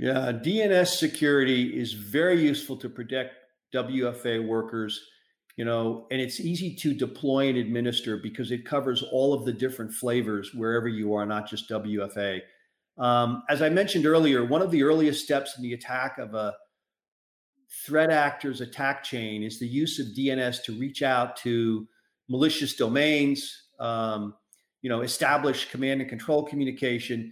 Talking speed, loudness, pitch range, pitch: 155 wpm, -27 LUFS, 115-145 Hz, 130 Hz